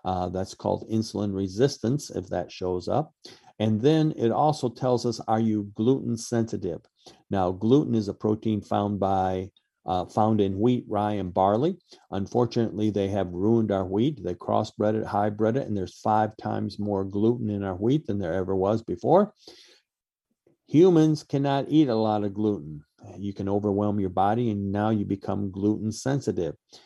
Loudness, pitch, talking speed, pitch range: -26 LUFS, 105 Hz, 170 wpm, 100-115 Hz